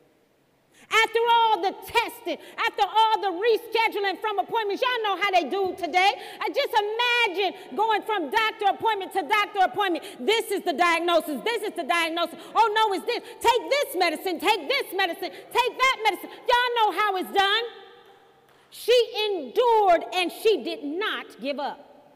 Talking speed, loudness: 160 wpm, -24 LUFS